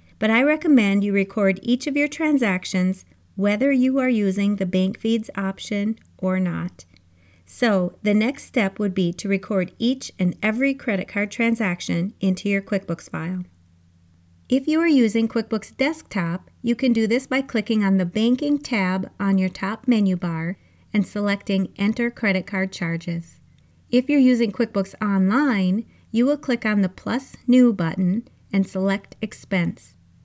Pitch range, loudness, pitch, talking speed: 185-235 Hz, -22 LUFS, 205 Hz, 160 wpm